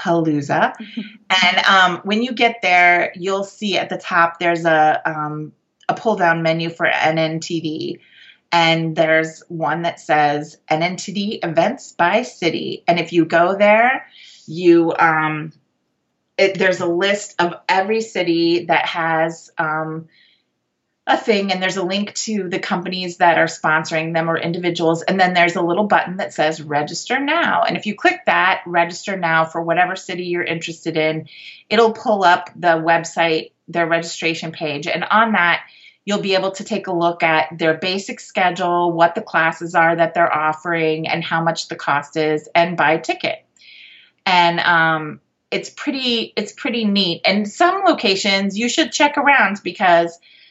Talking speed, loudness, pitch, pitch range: 165 wpm, -17 LUFS, 170 Hz, 165-195 Hz